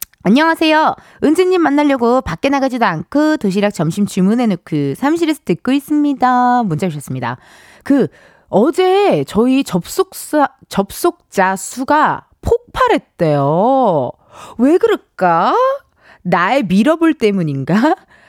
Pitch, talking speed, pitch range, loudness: 255 Hz, 255 characters per minute, 190-310 Hz, -14 LUFS